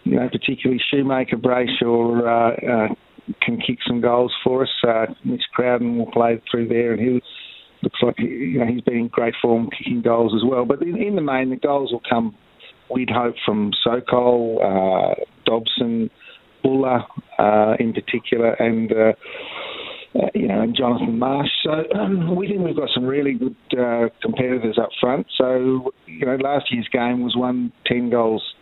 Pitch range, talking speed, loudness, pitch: 115-130 Hz, 180 wpm, -20 LUFS, 120 Hz